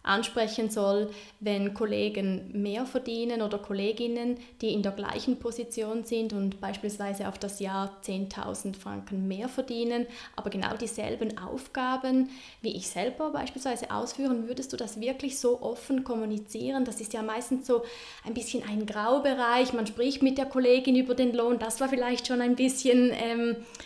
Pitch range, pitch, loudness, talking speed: 210-250 Hz, 235 Hz, -30 LUFS, 160 wpm